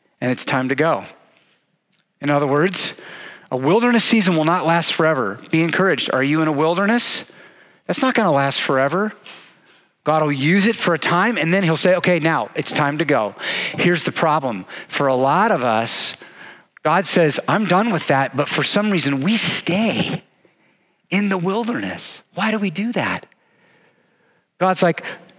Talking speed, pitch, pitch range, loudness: 175 wpm, 175 Hz, 155-195 Hz, -18 LUFS